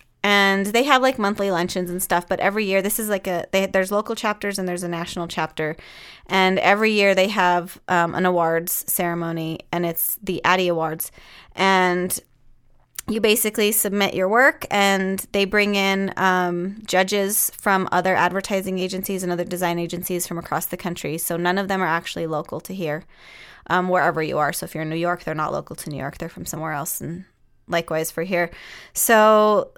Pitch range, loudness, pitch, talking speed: 170-195 Hz, -21 LUFS, 180 Hz, 195 wpm